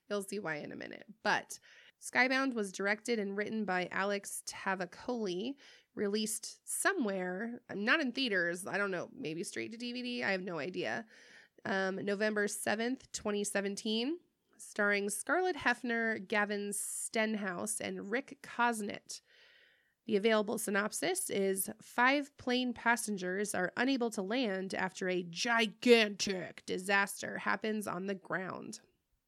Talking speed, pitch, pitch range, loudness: 130 wpm, 210 Hz, 195-240 Hz, -34 LUFS